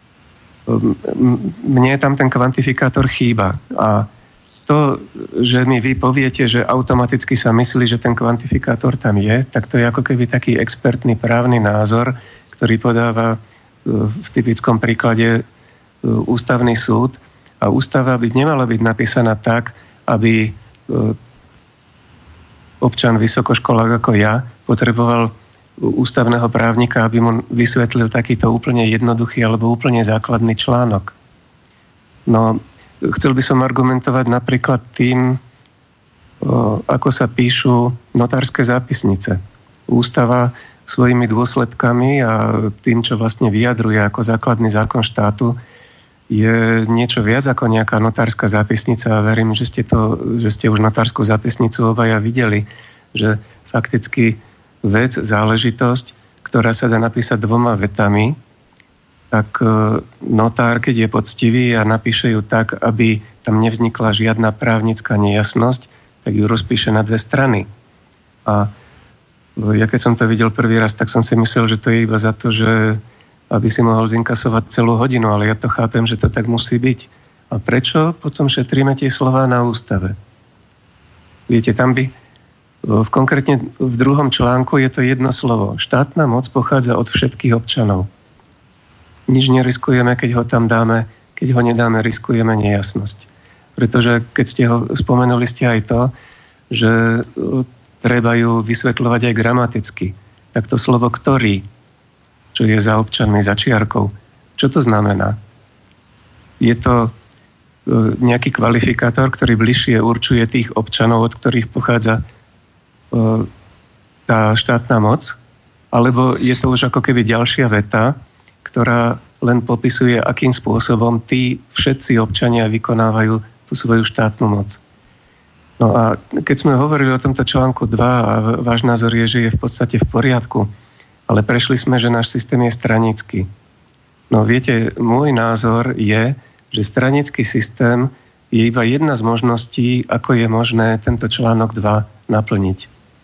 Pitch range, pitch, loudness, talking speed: 110-125 Hz, 115 Hz, -15 LUFS, 135 wpm